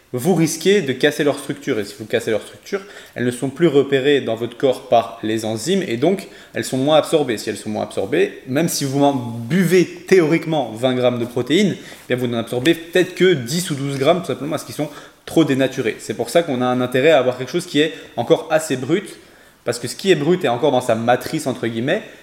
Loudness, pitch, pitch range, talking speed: -19 LUFS, 140 Hz, 125-165 Hz, 245 wpm